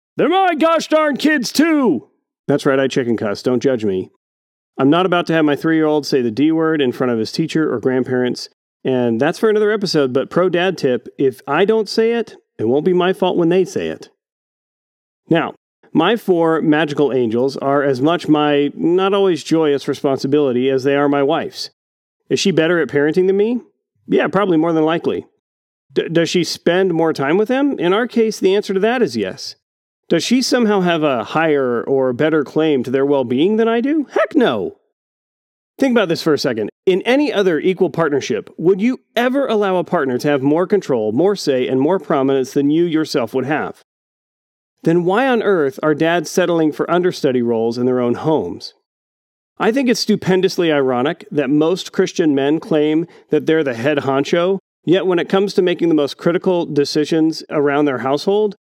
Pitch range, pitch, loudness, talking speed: 140-195 Hz, 160 Hz, -16 LUFS, 200 wpm